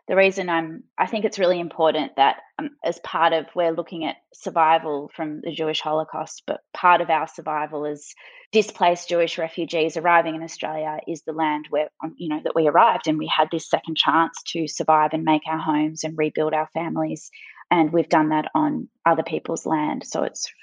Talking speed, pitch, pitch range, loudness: 200 wpm, 160 Hz, 155-170 Hz, -22 LUFS